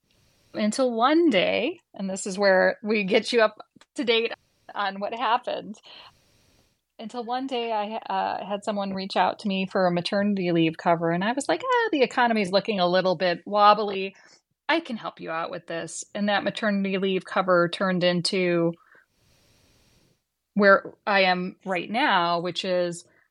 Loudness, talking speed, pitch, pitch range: -24 LUFS, 170 wpm, 200 Hz, 180-225 Hz